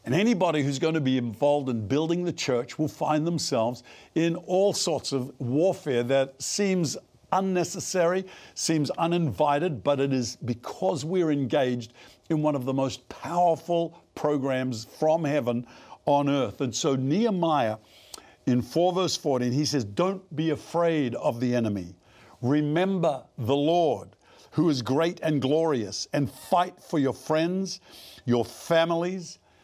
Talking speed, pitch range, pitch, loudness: 145 wpm, 130-170 Hz, 150 Hz, -26 LUFS